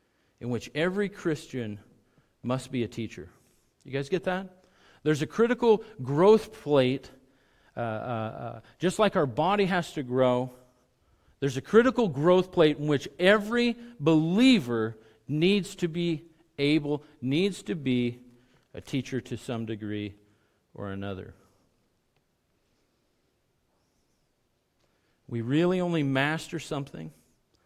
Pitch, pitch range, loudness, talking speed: 140 Hz, 120-180 Hz, -27 LUFS, 120 wpm